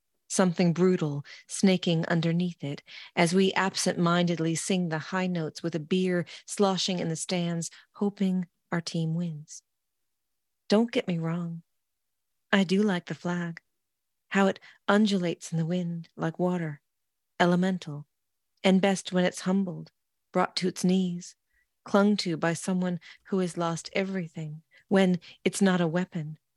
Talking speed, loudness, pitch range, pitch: 140 wpm, -28 LUFS, 165-190 Hz, 175 Hz